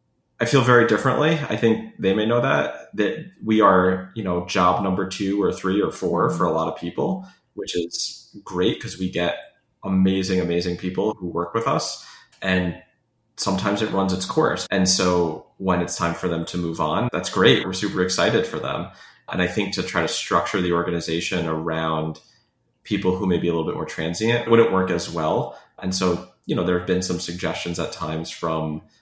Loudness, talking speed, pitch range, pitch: -22 LUFS, 205 wpm, 85-100 Hz, 90 Hz